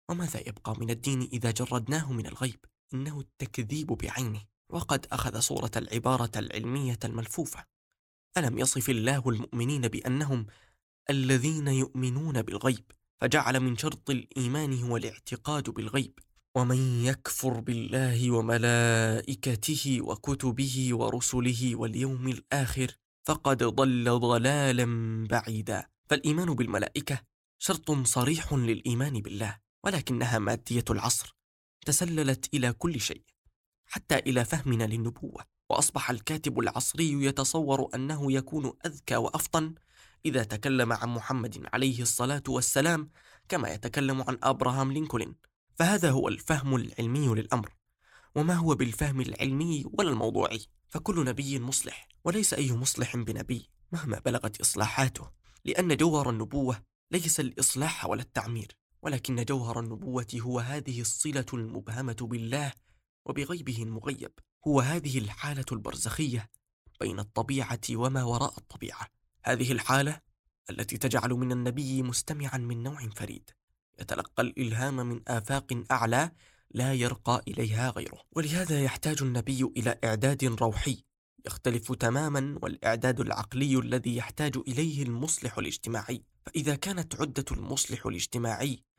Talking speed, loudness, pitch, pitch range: 115 wpm, -30 LUFS, 125 Hz, 115-140 Hz